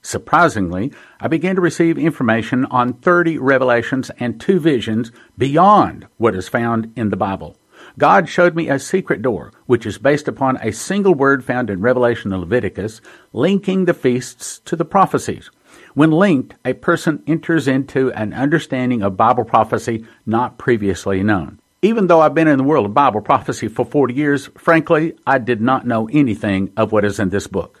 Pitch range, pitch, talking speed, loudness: 110-155 Hz, 125 Hz, 175 wpm, -16 LUFS